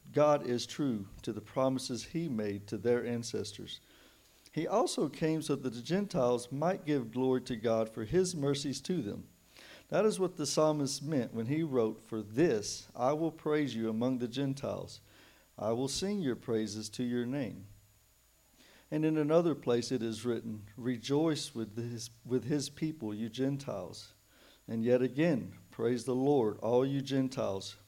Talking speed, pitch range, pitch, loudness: 170 wpm, 115-145 Hz, 125 Hz, -34 LUFS